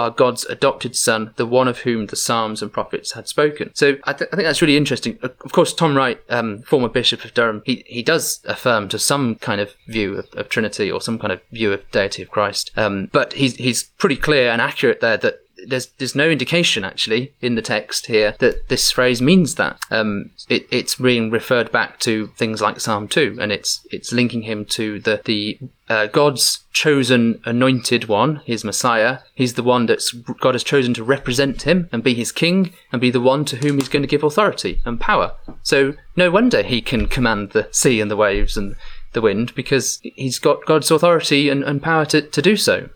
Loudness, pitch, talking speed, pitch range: -18 LUFS, 125 Hz, 215 wpm, 115-145 Hz